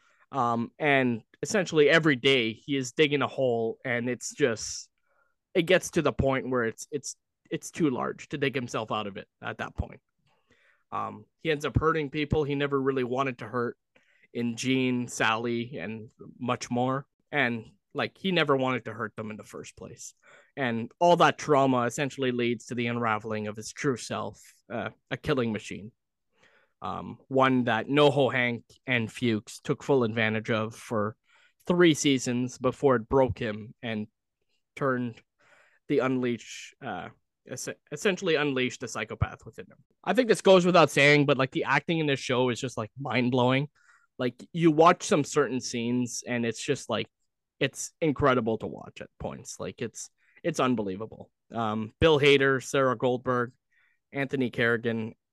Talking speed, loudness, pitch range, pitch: 165 wpm, -27 LUFS, 120-145 Hz, 130 Hz